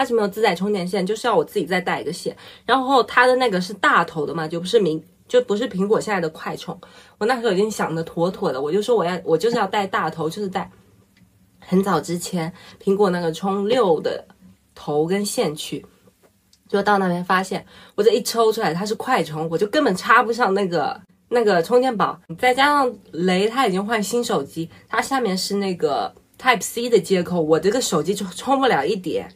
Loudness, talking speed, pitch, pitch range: -20 LUFS, 310 characters per minute, 205 Hz, 175-245 Hz